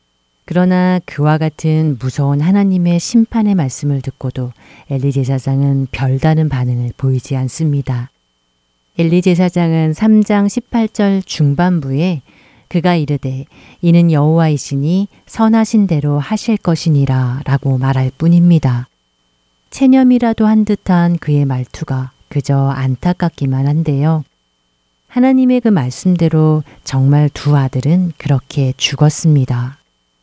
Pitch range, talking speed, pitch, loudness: 130-175 Hz, 260 characters per minute, 145 Hz, -14 LUFS